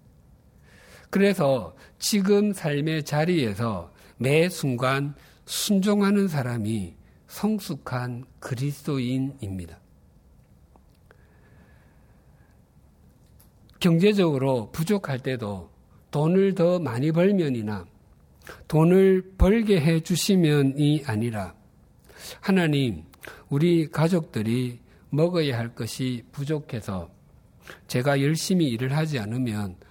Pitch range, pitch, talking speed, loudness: 105-165 Hz, 135 Hz, 190 characters per minute, -24 LUFS